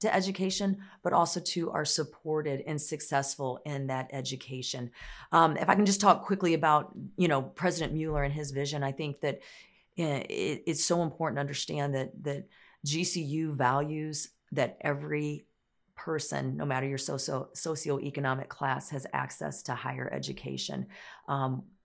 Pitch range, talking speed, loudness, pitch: 135-165 Hz, 150 wpm, -31 LUFS, 150 Hz